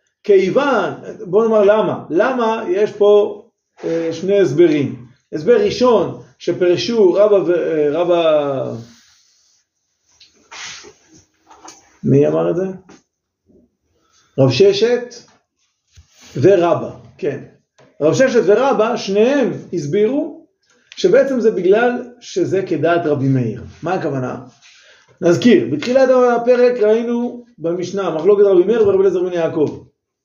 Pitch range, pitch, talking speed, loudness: 165-245 Hz, 205 Hz, 100 wpm, -15 LUFS